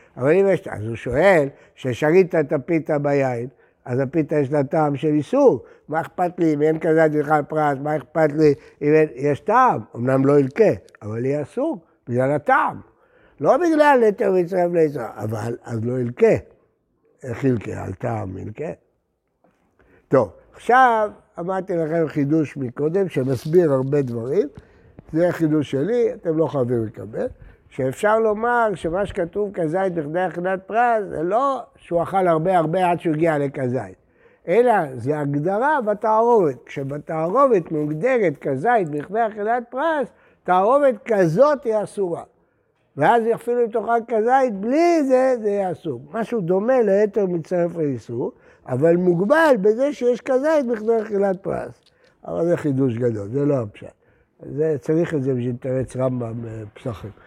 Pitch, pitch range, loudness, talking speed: 160 Hz, 140-215 Hz, -20 LUFS, 145 wpm